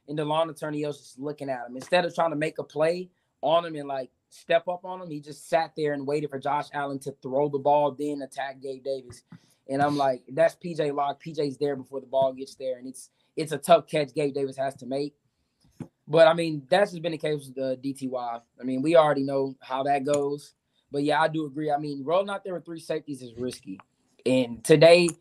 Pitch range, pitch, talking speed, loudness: 135-160 Hz, 145 Hz, 240 wpm, -26 LUFS